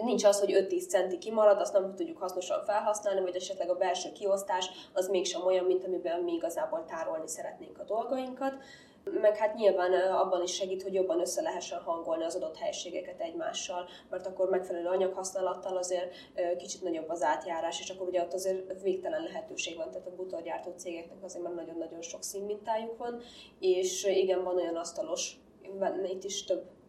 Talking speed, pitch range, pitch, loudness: 170 wpm, 180-215 Hz, 190 Hz, -32 LUFS